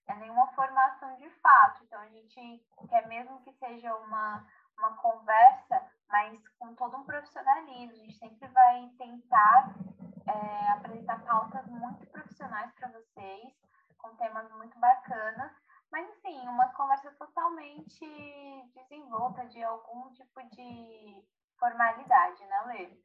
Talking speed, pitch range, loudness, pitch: 130 wpm, 225-295 Hz, -27 LUFS, 250 Hz